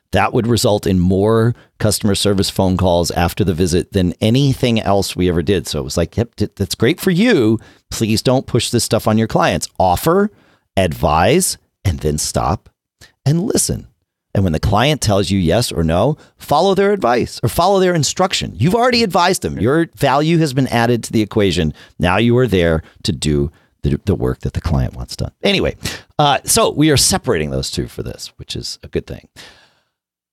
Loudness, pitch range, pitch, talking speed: -16 LUFS, 90-125 Hz, 105 Hz, 195 wpm